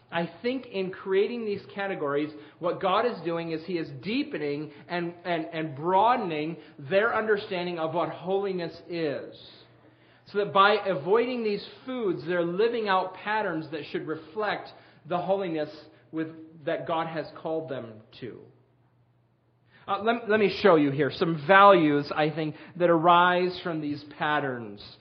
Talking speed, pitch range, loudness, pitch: 150 wpm, 150-195 Hz, -27 LUFS, 170 Hz